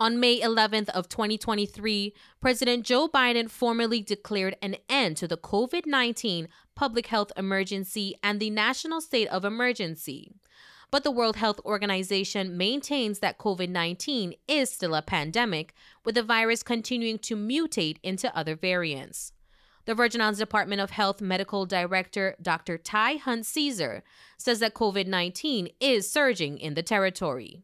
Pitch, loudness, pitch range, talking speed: 215 Hz, -27 LUFS, 190-240 Hz, 140 wpm